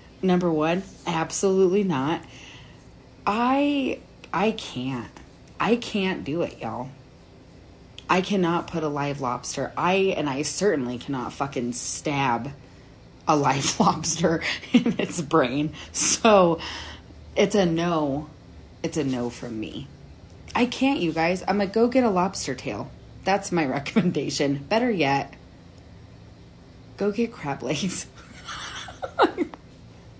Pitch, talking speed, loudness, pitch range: 165 Hz, 120 wpm, -24 LUFS, 135-195 Hz